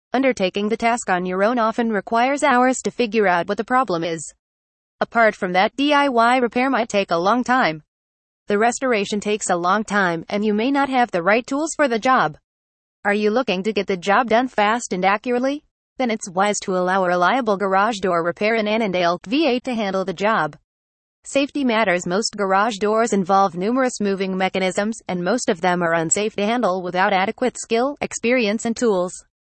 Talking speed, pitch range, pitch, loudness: 190 wpm, 185-235 Hz, 205 Hz, -19 LUFS